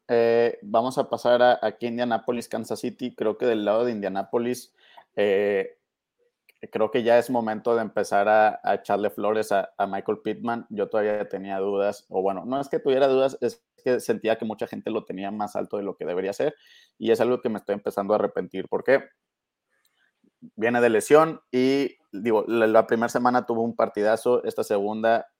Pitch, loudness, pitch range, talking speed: 115 Hz, -24 LUFS, 110-130 Hz, 190 wpm